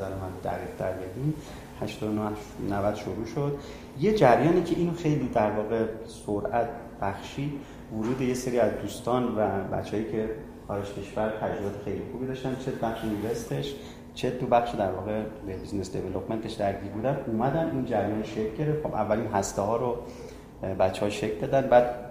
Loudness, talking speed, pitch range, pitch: -29 LUFS, 155 wpm, 100-125 Hz, 110 Hz